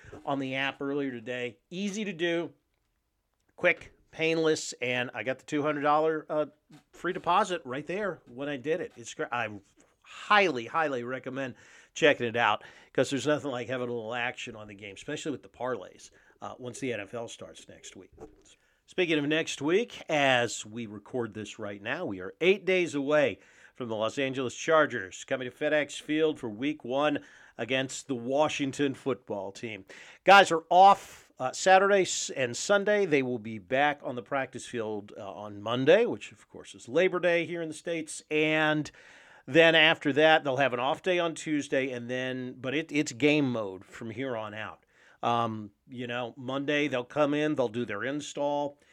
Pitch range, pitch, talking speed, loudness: 120-155 Hz, 140 Hz, 185 wpm, -28 LUFS